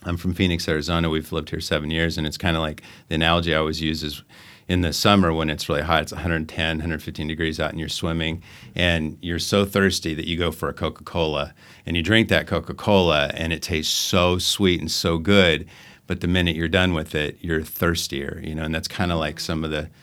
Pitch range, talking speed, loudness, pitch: 80-90 Hz, 235 wpm, -22 LUFS, 80 Hz